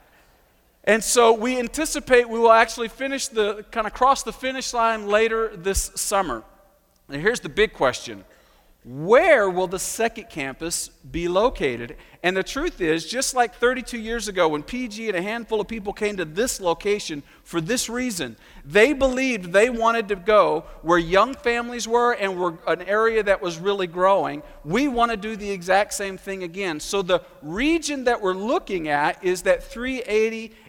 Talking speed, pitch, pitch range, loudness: 175 wpm, 215 Hz, 185-240 Hz, -22 LUFS